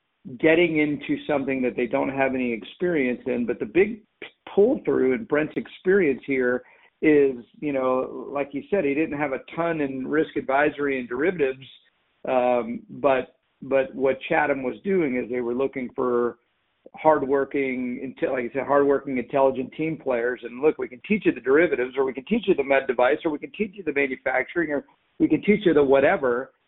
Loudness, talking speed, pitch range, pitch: -24 LUFS, 190 wpm, 130-155 Hz, 140 Hz